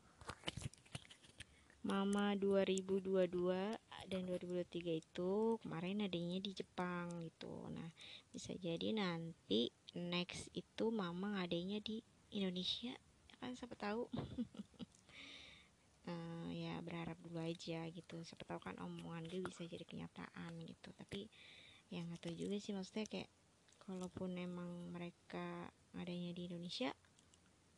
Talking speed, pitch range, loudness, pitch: 110 wpm, 170-200 Hz, -45 LUFS, 180 Hz